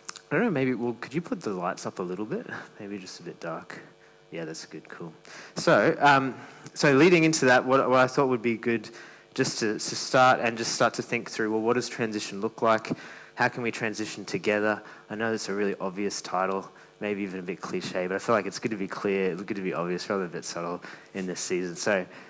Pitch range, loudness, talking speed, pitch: 95-125 Hz, -27 LUFS, 250 wpm, 110 Hz